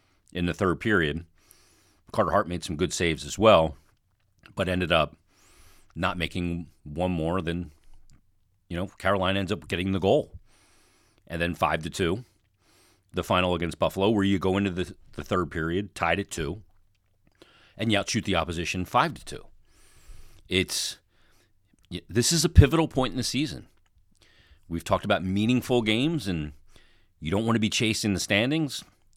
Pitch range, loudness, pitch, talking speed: 85-105 Hz, -26 LUFS, 95 Hz, 165 wpm